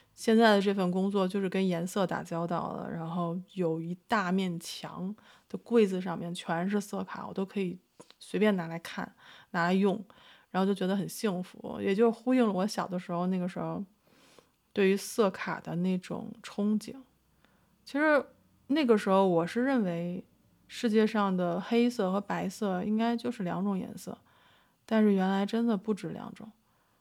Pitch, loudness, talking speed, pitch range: 195 Hz, -30 LUFS, 250 characters per minute, 180-225 Hz